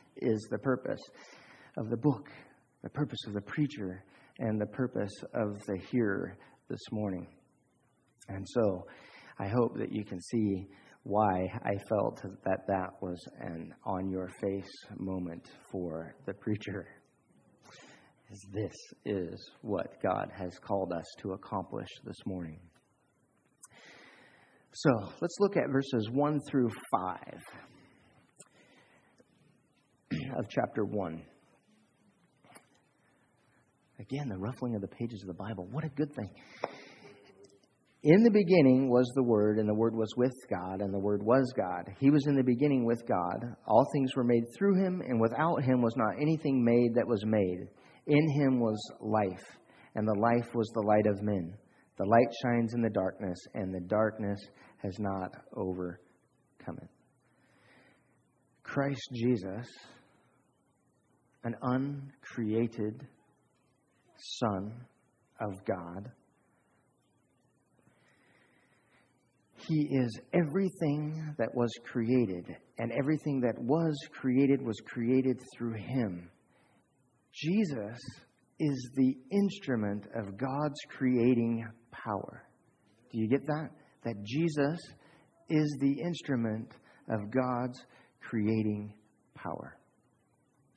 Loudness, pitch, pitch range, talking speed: -32 LUFS, 120 Hz, 105-135 Hz, 120 wpm